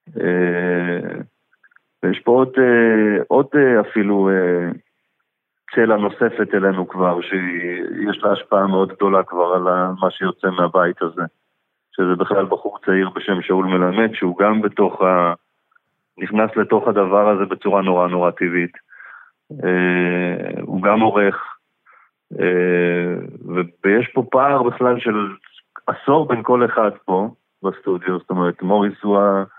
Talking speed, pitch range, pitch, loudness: 130 wpm, 90-105 Hz, 95 Hz, -18 LUFS